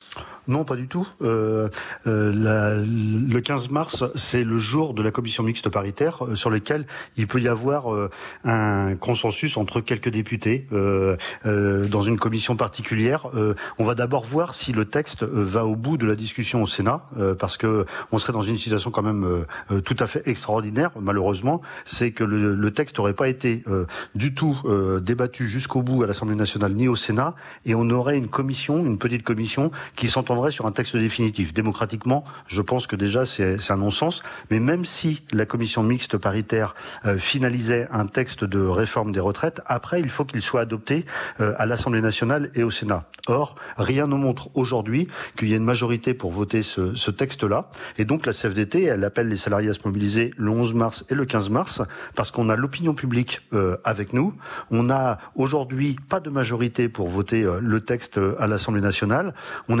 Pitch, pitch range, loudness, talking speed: 115 Hz, 105-130 Hz, -23 LUFS, 200 wpm